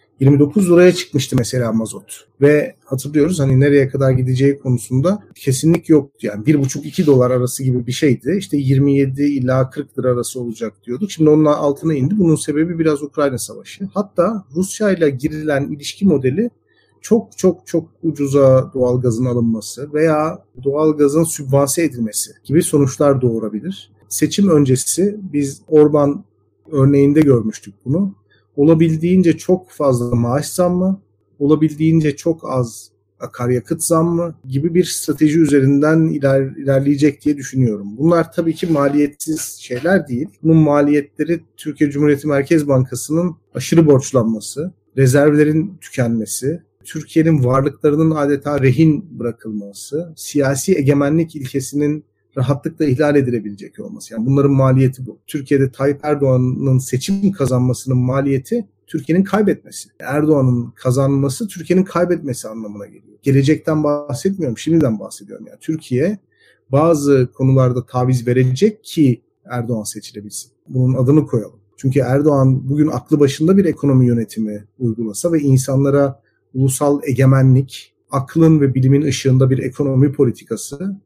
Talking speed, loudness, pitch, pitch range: 120 wpm, -16 LUFS, 140 Hz, 130-155 Hz